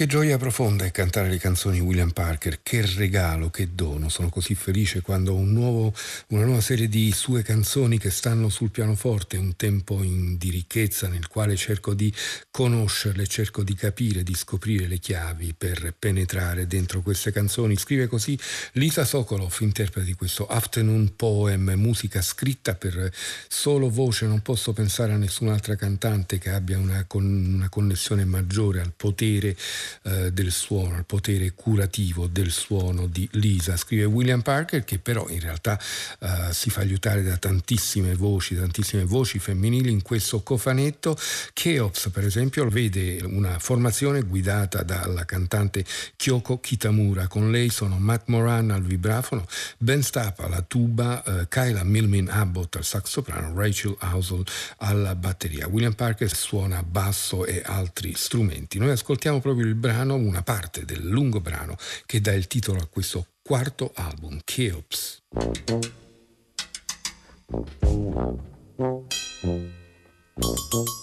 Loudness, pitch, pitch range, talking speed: -25 LUFS, 100 Hz, 95-115 Hz, 145 wpm